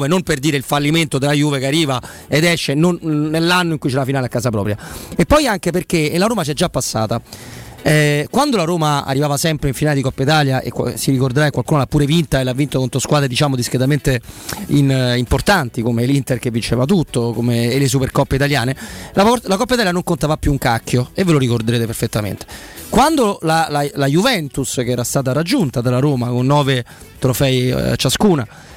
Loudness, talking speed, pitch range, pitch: -16 LUFS, 205 wpm, 125-155 Hz, 140 Hz